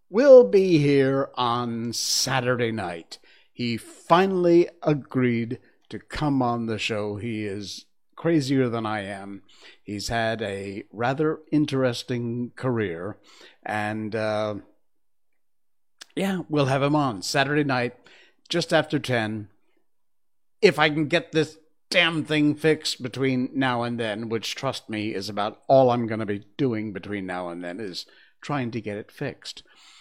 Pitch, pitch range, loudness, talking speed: 125 Hz, 110-150 Hz, -24 LUFS, 140 wpm